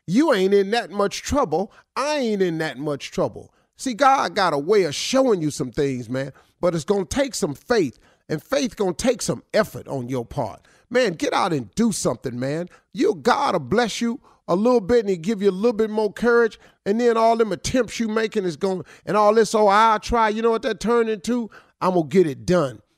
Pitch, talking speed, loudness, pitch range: 210 Hz, 225 wpm, -21 LUFS, 170-235 Hz